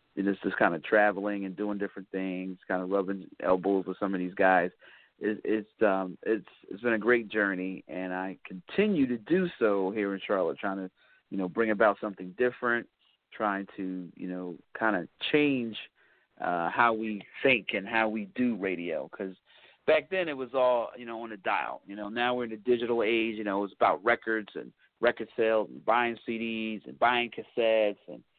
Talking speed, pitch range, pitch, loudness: 200 wpm, 95-115 Hz, 105 Hz, -29 LUFS